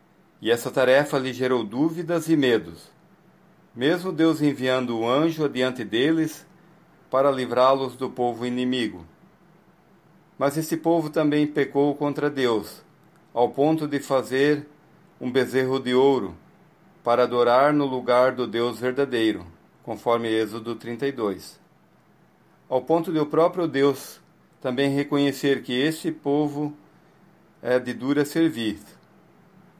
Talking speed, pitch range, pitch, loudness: 125 wpm, 125-160 Hz, 140 Hz, -23 LUFS